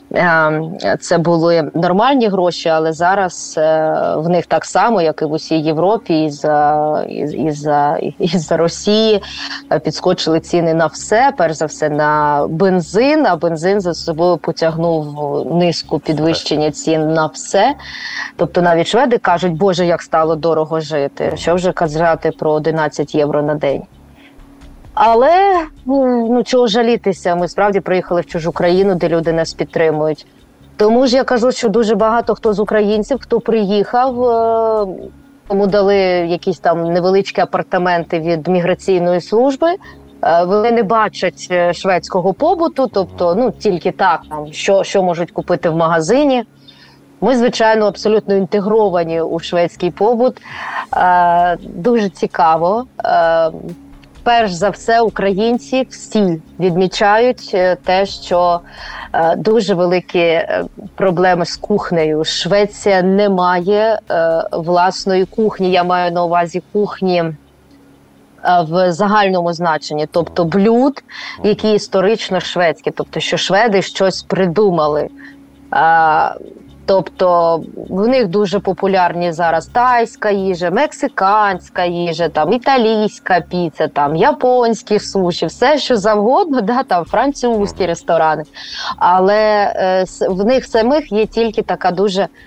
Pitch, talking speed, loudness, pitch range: 185 Hz, 120 wpm, -14 LUFS, 165-215 Hz